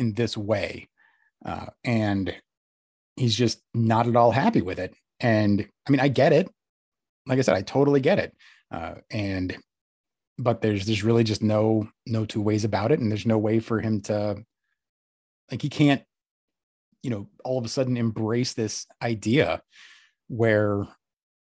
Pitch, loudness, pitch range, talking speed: 110 Hz, -24 LUFS, 105-120 Hz, 165 wpm